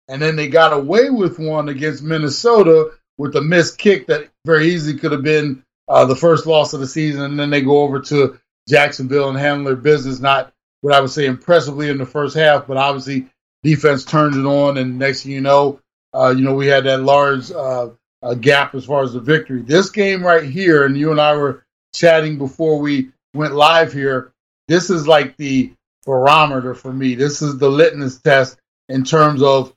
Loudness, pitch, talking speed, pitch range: -15 LUFS, 145 Hz, 205 wpm, 135-155 Hz